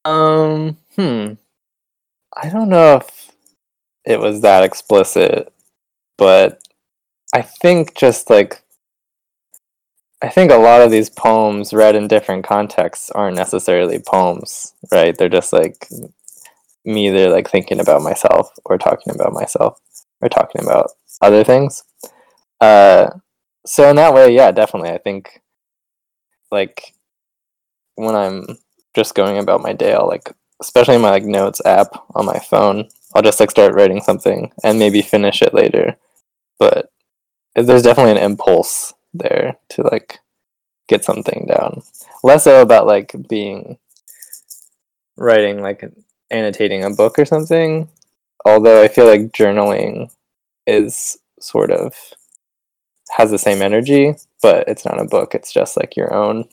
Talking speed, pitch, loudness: 140 wpm, 155 Hz, -12 LUFS